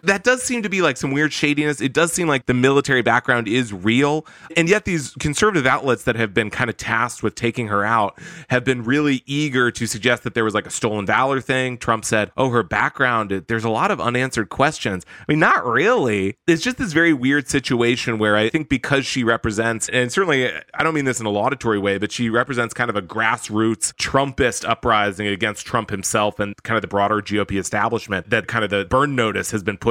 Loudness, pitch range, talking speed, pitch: -19 LUFS, 110-140 Hz, 225 wpm, 120 Hz